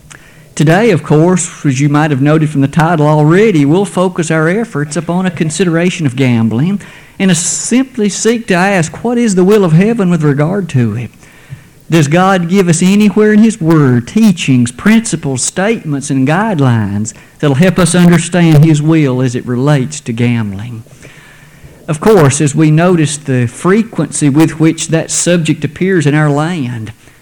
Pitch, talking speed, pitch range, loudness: 160 Hz, 170 wpm, 145-185 Hz, -10 LUFS